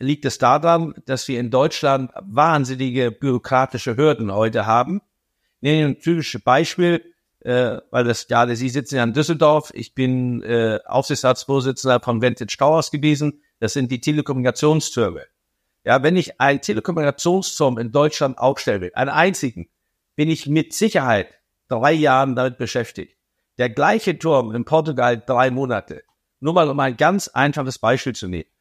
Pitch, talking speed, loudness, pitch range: 135 Hz, 155 wpm, -19 LUFS, 125-150 Hz